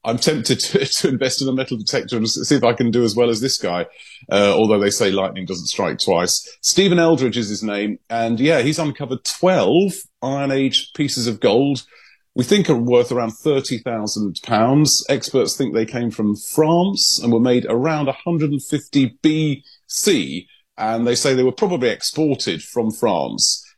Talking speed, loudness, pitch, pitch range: 190 wpm, -18 LUFS, 130 Hz, 115-150 Hz